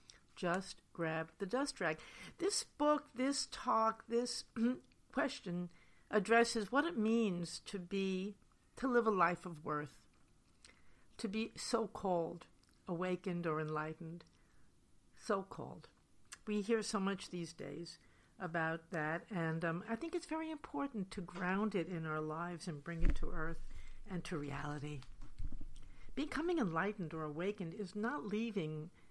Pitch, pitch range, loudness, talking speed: 185 Hz, 160-225 Hz, -40 LUFS, 140 wpm